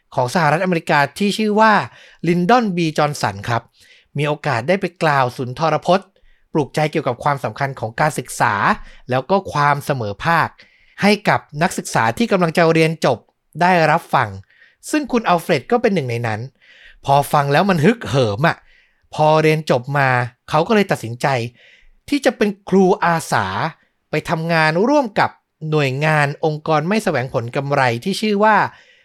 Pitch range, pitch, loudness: 140-185 Hz, 155 Hz, -17 LUFS